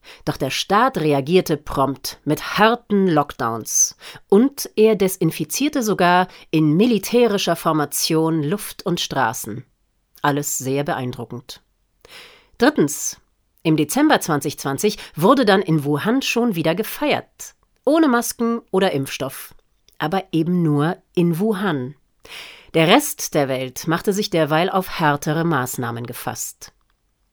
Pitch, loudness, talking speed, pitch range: 170 Hz, -19 LUFS, 115 wpm, 145-210 Hz